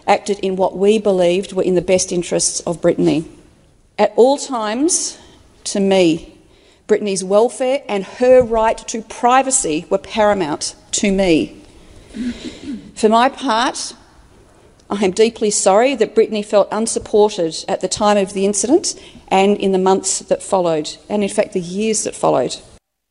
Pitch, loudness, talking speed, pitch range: 205 Hz, -16 LUFS, 150 wpm, 190-230 Hz